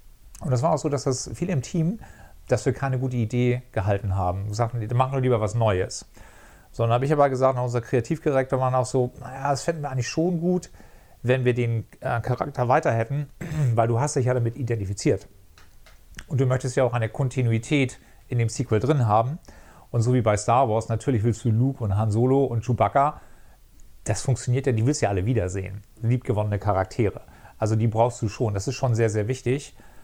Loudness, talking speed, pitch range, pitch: -24 LUFS, 205 wpm, 110-135 Hz, 125 Hz